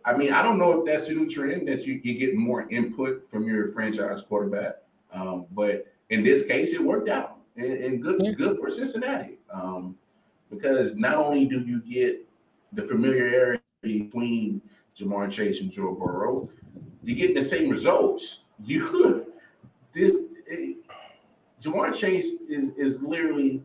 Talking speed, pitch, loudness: 160 wpm, 140 Hz, -26 LUFS